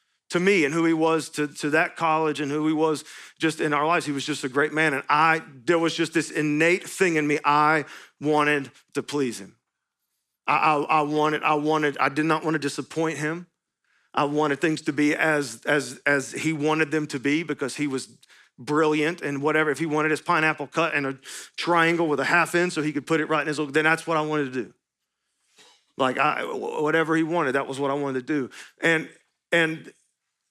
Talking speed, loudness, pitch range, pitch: 220 wpm, -24 LUFS, 145-160 Hz, 155 Hz